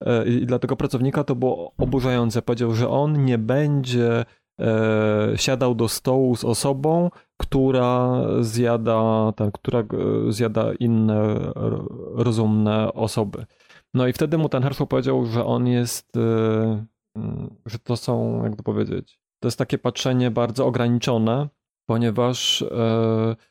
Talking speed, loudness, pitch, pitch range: 125 wpm, -22 LUFS, 120 Hz, 115-130 Hz